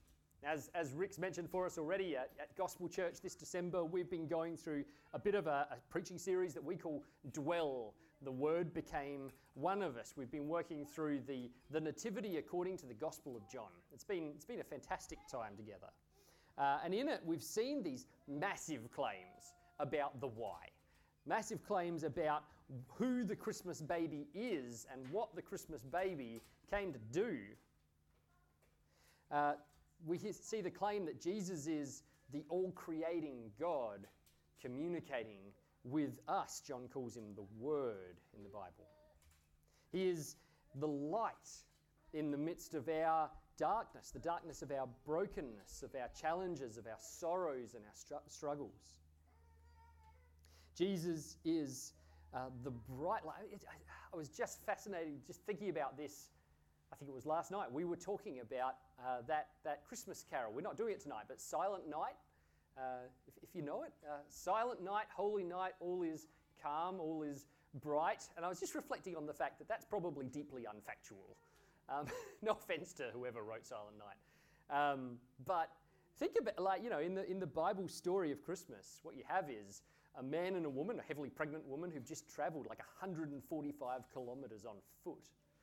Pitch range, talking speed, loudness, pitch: 125-175 Hz, 170 wpm, -44 LUFS, 150 Hz